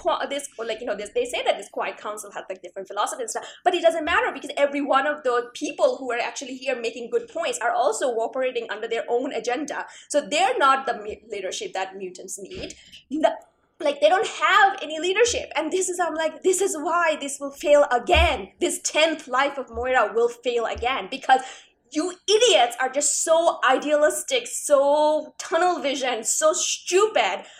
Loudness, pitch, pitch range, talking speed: -23 LUFS, 295 Hz, 250-335 Hz, 190 wpm